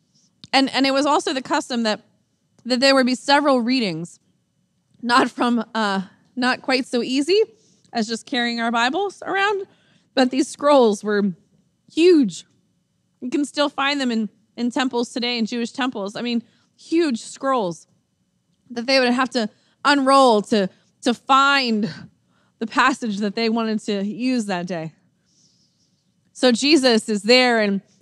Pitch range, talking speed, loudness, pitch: 215-270 Hz, 150 wpm, -20 LUFS, 240 Hz